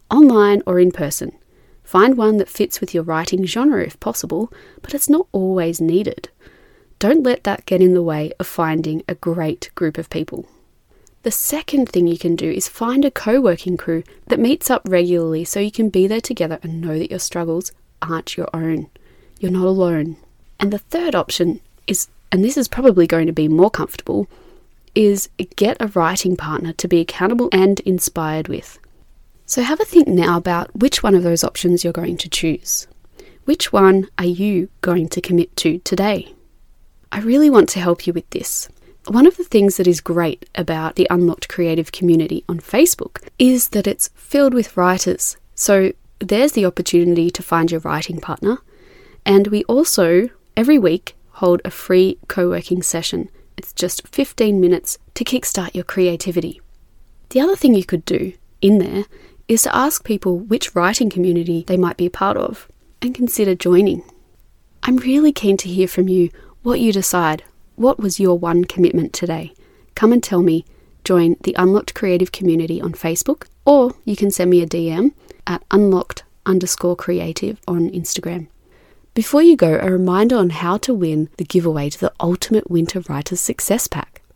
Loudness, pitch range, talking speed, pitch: -17 LUFS, 170-220 Hz, 180 wpm, 185 Hz